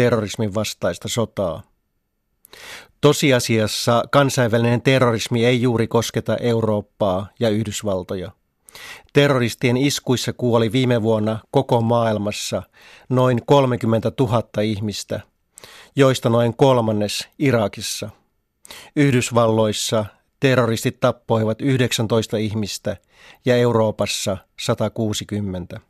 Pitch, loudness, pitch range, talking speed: 115 Hz, -19 LUFS, 110-125 Hz, 80 wpm